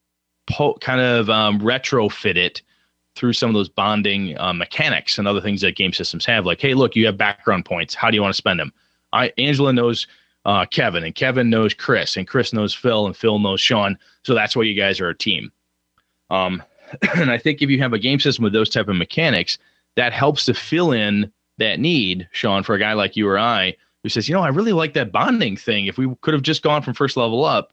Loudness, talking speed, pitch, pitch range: -18 LUFS, 235 wpm, 110 Hz, 100-130 Hz